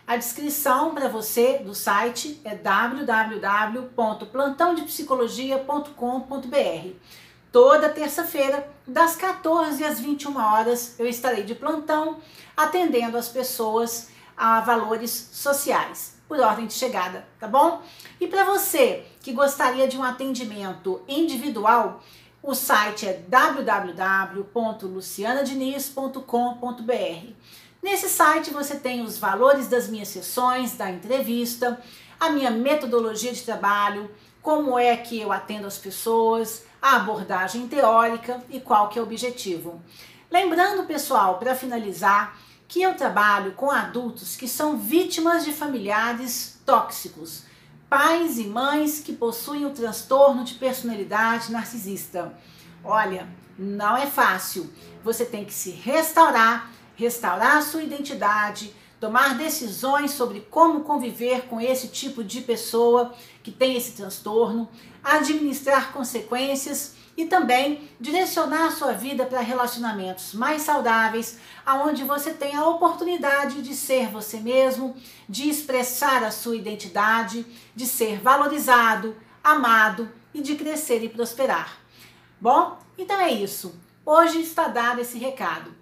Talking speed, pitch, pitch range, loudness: 120 wpm, 245 Hz, 220-285 Hz, -23 LUFS